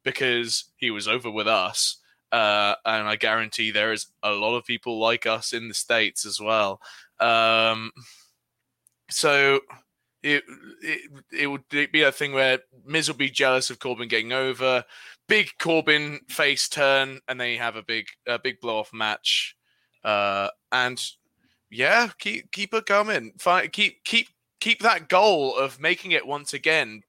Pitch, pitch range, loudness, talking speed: 130 Hz, 115-150 Hz, -23 LUFS, 160 wpm